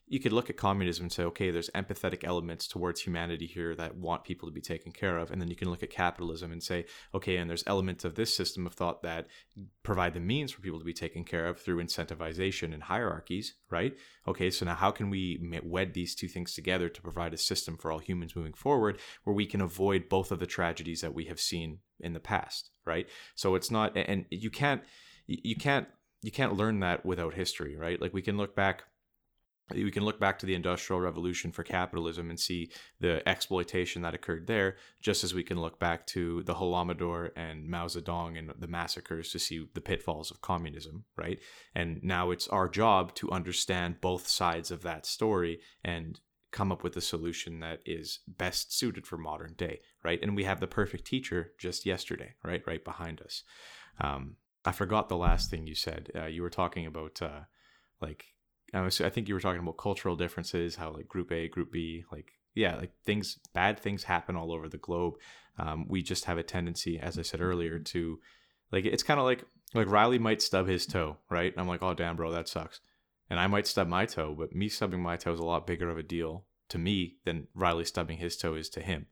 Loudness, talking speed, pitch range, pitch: -33 LUFS, 220 wpm, 85-95 Hz, 90 Hz